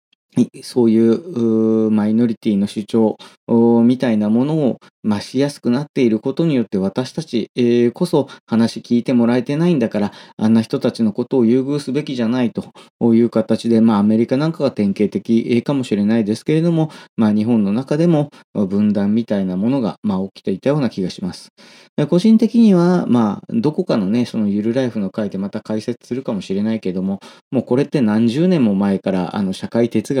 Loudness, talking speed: -17 LUFS, 390 characters per minute